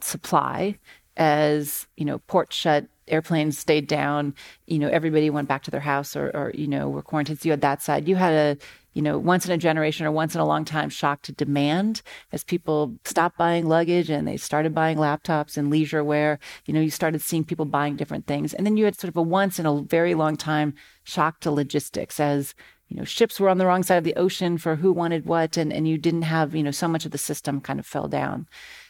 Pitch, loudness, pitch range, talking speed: 155 Hz, -24 LUFS, 150-170 Hz, 240 wpm